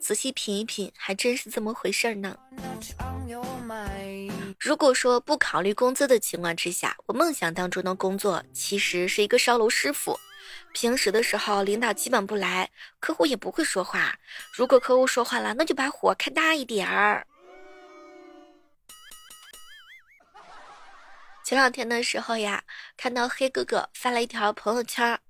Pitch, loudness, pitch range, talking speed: 235 Hz, -25 LUFS, 200-265 Hz, 230 characters per minute